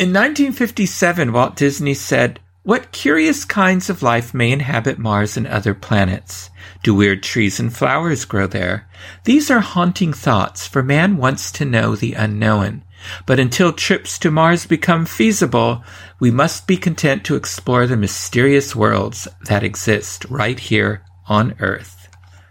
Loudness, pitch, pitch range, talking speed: -16 LUFS, 115 Hz, 100-150 Hz, 150 wpm